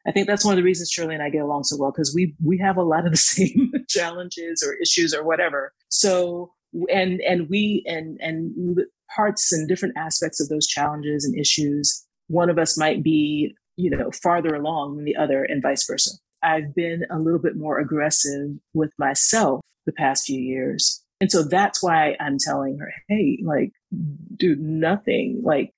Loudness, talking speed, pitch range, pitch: -21 LUFS, 195 wpm, 150-185 Hz, 165 Hz